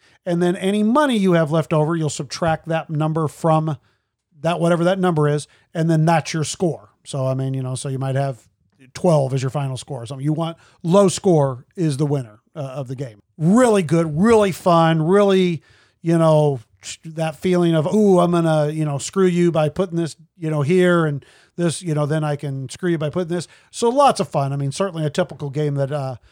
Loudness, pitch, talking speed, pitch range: -19 LUFS, 155 Hz, 225 wpm, 140-175 Hz